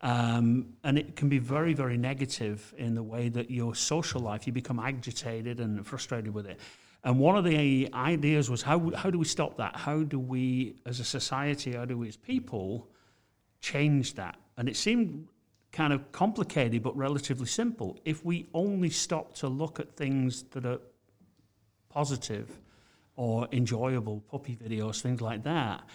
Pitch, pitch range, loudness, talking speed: 130 Hz, 115-150 Hz, -31 LUFS, 170 wpm